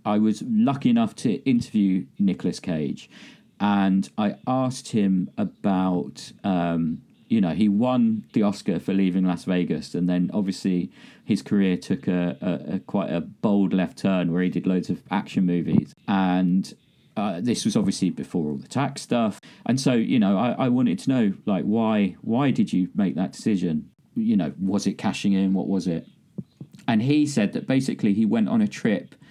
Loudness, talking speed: -24 LUFS, 185 wpm